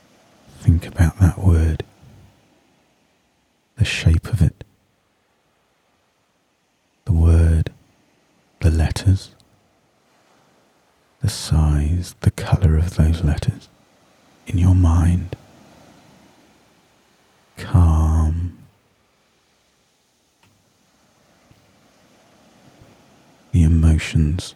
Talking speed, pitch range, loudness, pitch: 60 wpm, 80-95 Hz, -19 LUFS, 85 Hz